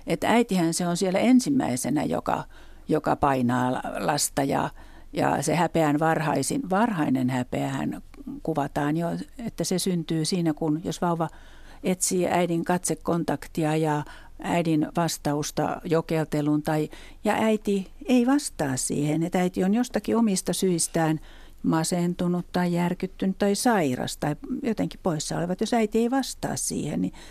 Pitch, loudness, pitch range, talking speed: 175 Hz, -25 LUFS, 155-200 Hz, 130 wpm